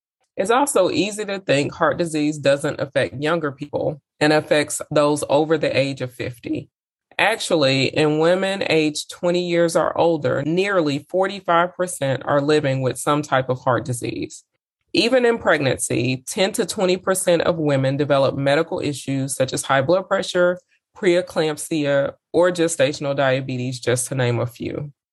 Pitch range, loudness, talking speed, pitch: 135-175 Hz, -20 LUFS, 150 wpm, 150 Hz